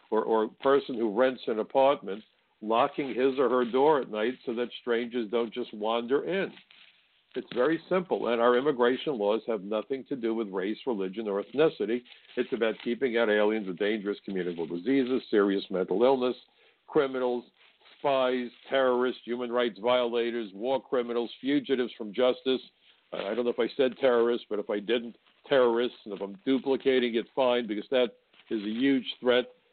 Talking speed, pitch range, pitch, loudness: 170 wpm, 110-130 Hz, 120 Hz, -28 LUFS